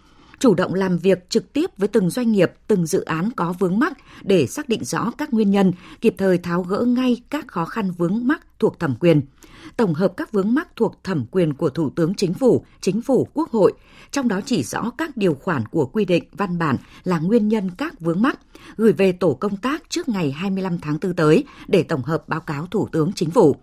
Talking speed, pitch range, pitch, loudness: 230 wpm, 175-235 Hz, 195 Hz, -21 LUFS